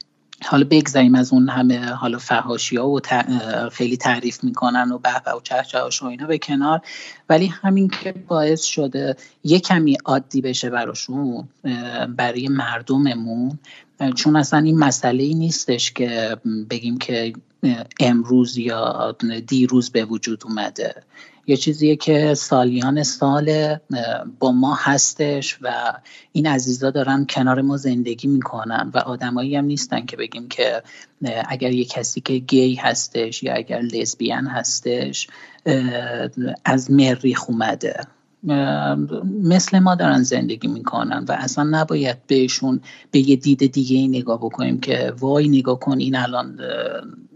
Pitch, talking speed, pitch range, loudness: 130 Hz, 135 wpm, 120-140 Hz, -19 LUFS